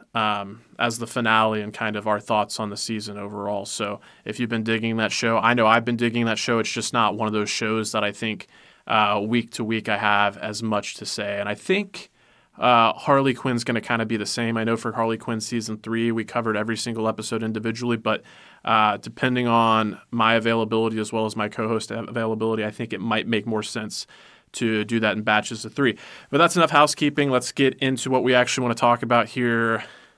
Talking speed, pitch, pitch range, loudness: 230 wpm, 115 Hz, 110-120 Hz, -23 LUFS